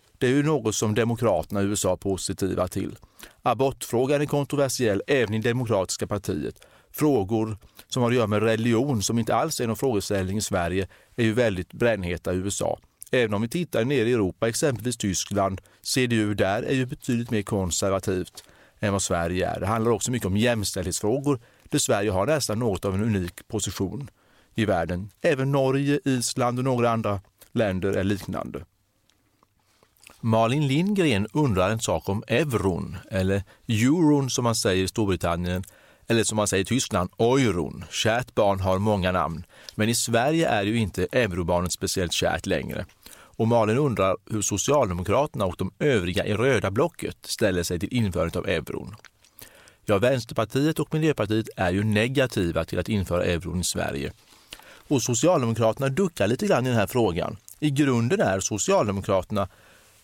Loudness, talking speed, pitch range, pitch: -25 LUFS, 165 wpm, 95-125 Hz, 110 Hz